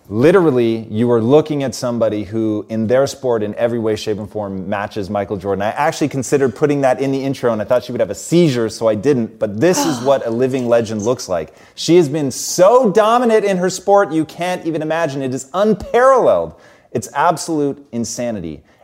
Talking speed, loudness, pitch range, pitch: 205 wpm, -16 LUFS, 110-155 Hz, 130 Hz